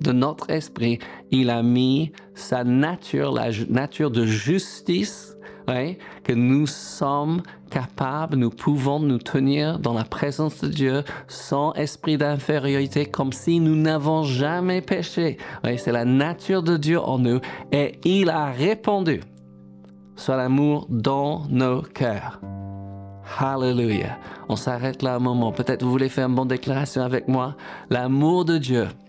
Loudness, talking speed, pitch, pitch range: -23 LUFS, 150 wpm, 135 Hz, 125-155 Hz